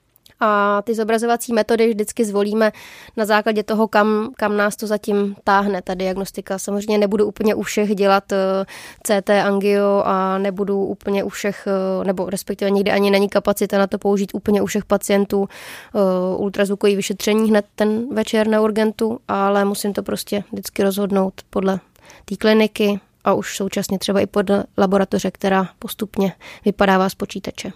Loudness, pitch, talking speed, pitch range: -19 LUFS, 205 Hz, 160 wpm, 195-215 Hz